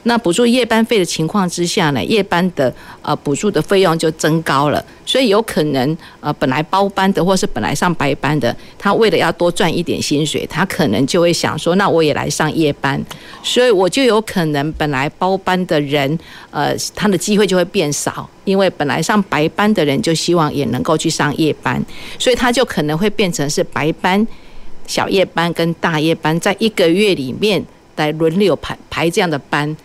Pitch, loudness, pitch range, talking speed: 165 Hz, -15 LUFS, 150-195 Hz, 285 characters per minute